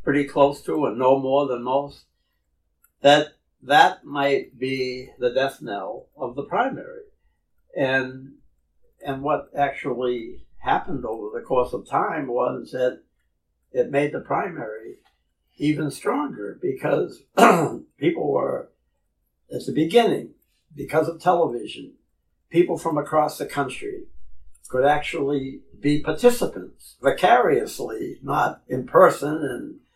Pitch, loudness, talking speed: 145 Hz, -22 LUFS, 120 wpm